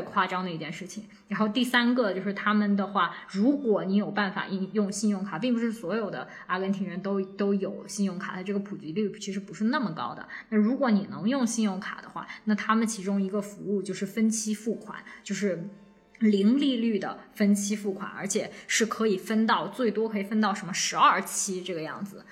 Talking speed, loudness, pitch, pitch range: 315 characters per minute, -28 LUFS, 205 Hz, 195-220 Hz